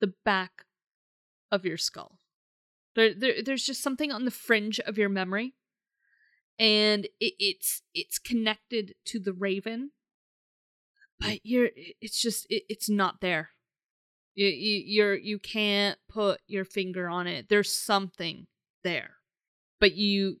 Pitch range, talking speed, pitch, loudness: 195-235 Hz, 140 wpm, 210 Hz, -28 LUFS